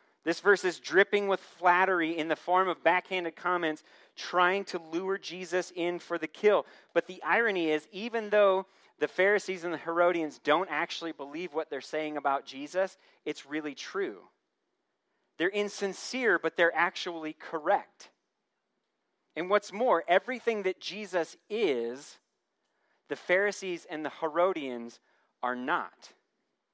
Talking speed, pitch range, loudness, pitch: 140 wpm, 160-195 Hz, -30 LUFS, 180 Hz